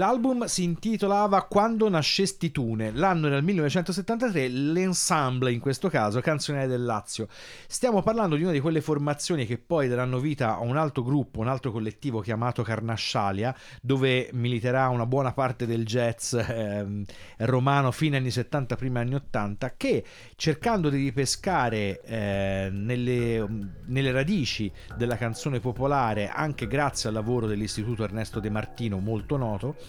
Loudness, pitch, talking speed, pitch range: -27 LUFS, 130 Hz, 145 wpm, 115-150 Hz